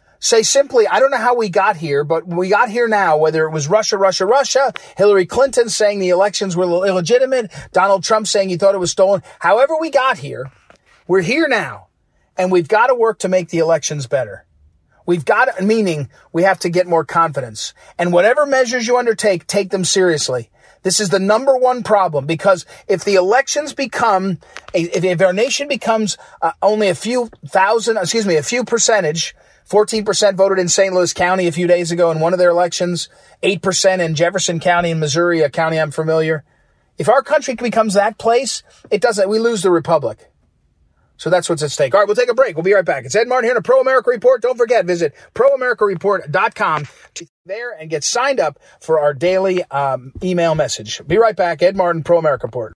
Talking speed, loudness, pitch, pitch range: 205 wpm, -15 LUFS, 190 Hz, 165-225 Hz